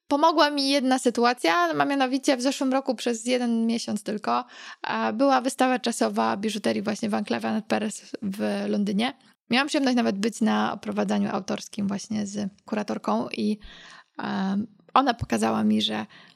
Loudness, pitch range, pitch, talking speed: -25 LUFS, 200-255 Hz, 220 Hz, 145 wpm